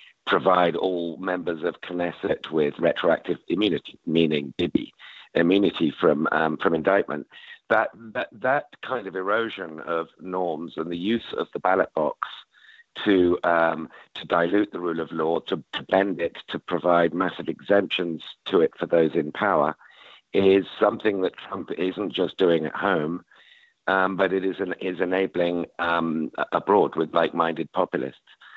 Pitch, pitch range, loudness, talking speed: 85 Hz, 85-95 Hz, -24 LUFS, 150 wpm